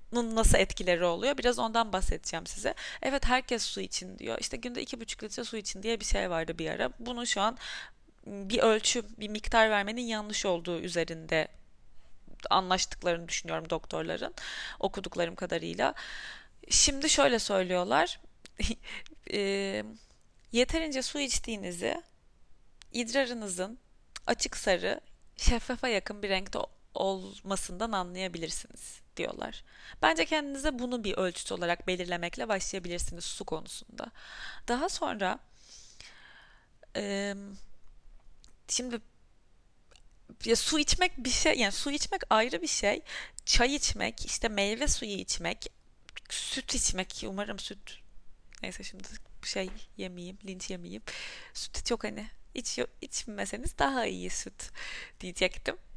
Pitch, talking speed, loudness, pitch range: 210 Hz, 115 wpm, -31 LUFS, 185-245 Hz